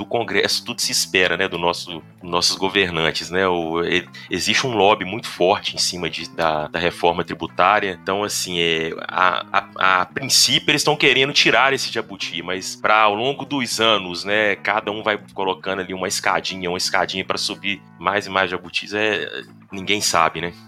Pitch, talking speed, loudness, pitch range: 95 Hz, 185 wpm, -19 LUFS, 85-105 Hz